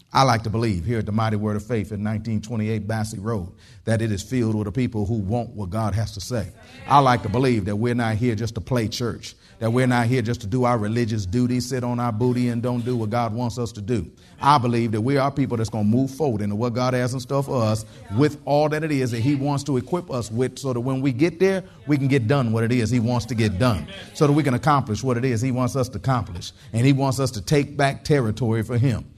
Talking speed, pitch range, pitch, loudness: 280 wpm, 110-130 Hz, 120 Hz, -22 LUFS